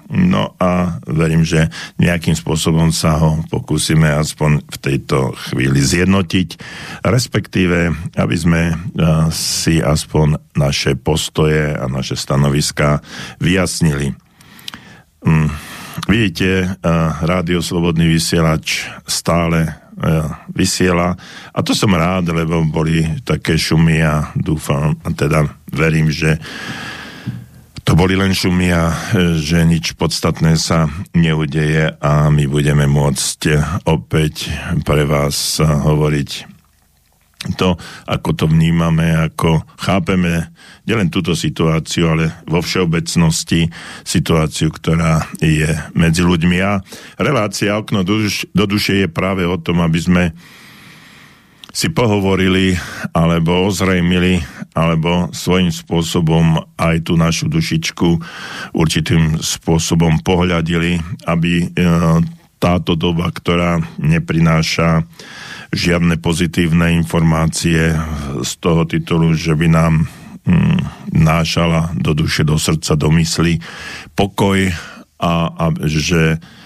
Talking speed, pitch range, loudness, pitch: 105 wpm, 80-90 Hz, -15 LUFS, 85 Hz